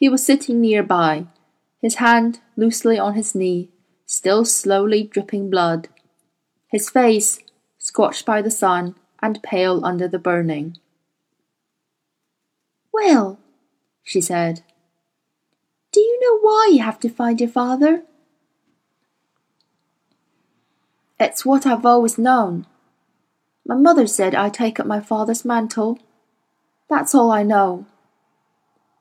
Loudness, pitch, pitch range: -18 LUFS, 215 Hz, 180-240 Hz